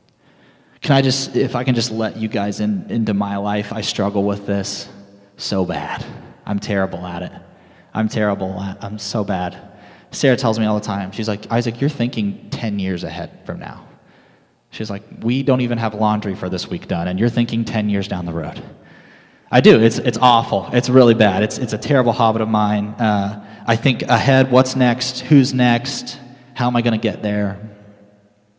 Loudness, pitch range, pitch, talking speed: -18 LUFS, 100-120 Hz, 110 Hz, 200 wpm